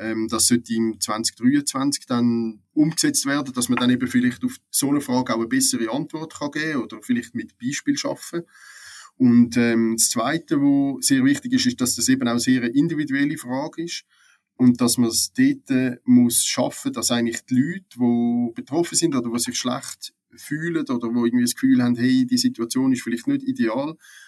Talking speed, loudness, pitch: 200 wpm, -21 LUFS, 150 Hz